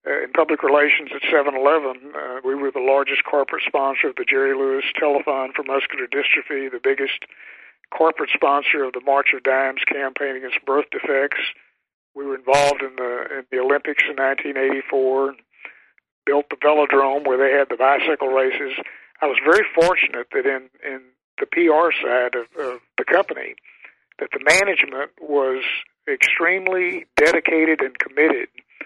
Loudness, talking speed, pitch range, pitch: -19 LUFS, 160 wpm, 135-160 Hz, 140 Hz